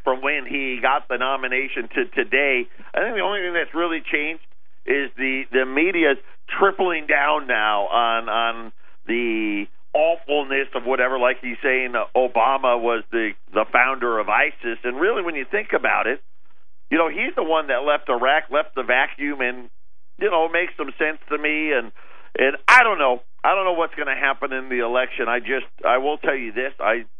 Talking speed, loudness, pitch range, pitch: 195 wpm, -21 LUFS, 120-150 Hz, 130 Hz